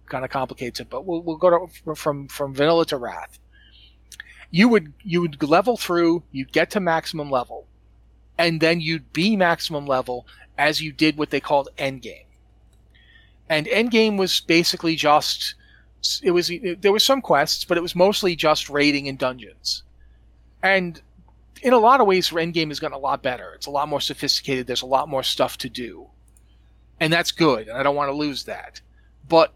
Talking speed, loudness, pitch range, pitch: 195 wpm, -21 LUFS, 130-170 Hz, 150 Hz